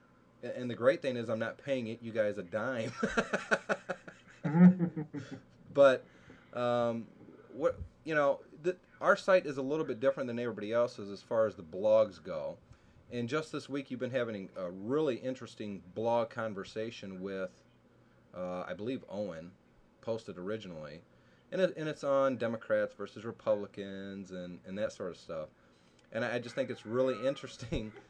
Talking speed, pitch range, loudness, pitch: 160 wpm, 100-135 Hz, -34 LUFS, 115 Hz